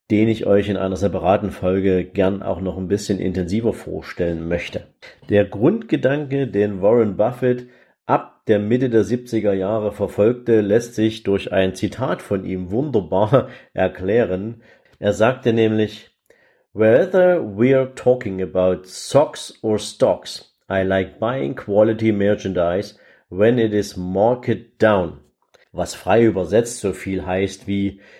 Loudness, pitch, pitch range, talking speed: -19 LUFS, 105 Hz, 95-115 Hz, 135 wpm